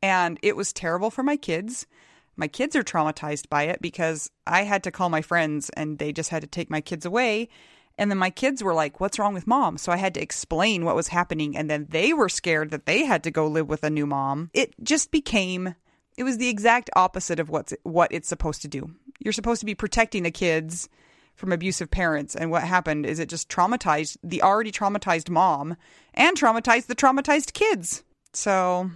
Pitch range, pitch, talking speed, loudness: 160-215 Hz, 175 Hz, 215 wpm, -24 LUFS